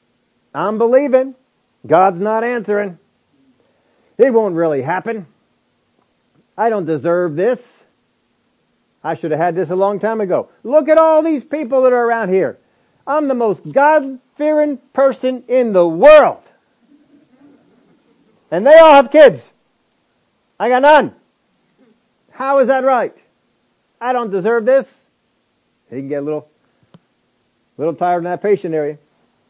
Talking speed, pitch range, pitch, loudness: 135 wpm, 190-275 Hz, 245 Hz, -14 LUFS